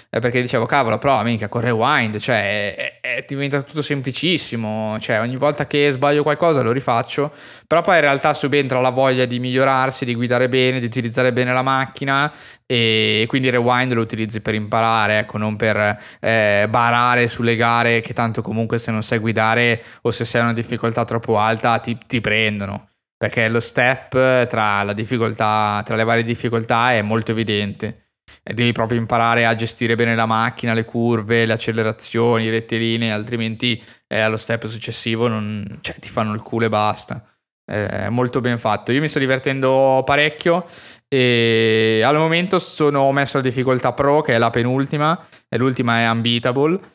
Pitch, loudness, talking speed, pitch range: 120 Hz, -18 LUFS, 170 wpm, 115-130 Hz